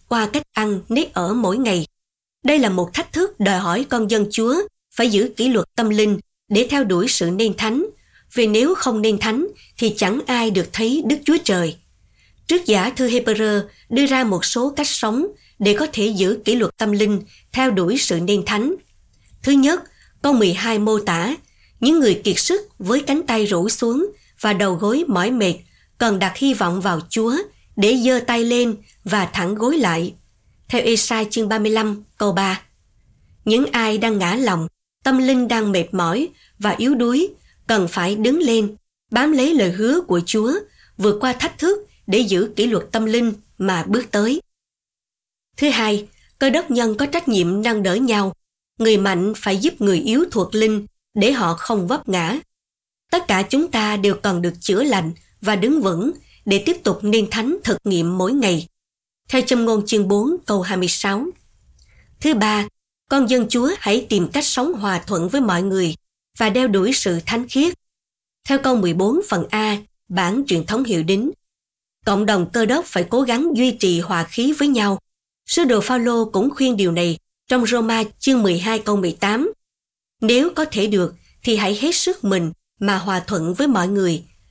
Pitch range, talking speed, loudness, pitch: 195-260 Hz, 185 wpm, -18 LUFS, 220 Hz